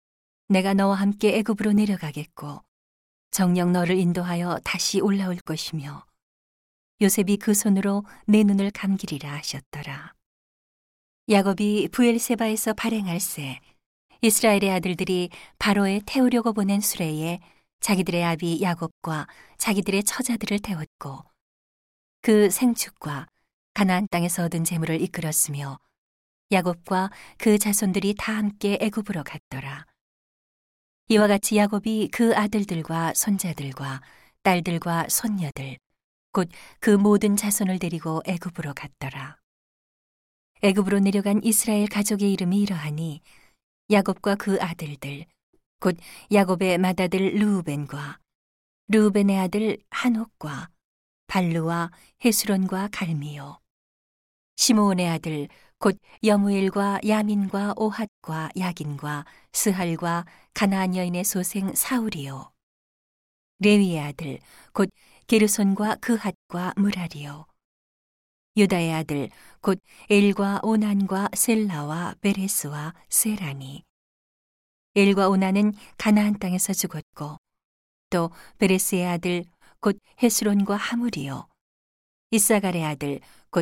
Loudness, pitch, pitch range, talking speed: -23 LUFS, 190 Hz, 165-205 Hz, 250 characters per minute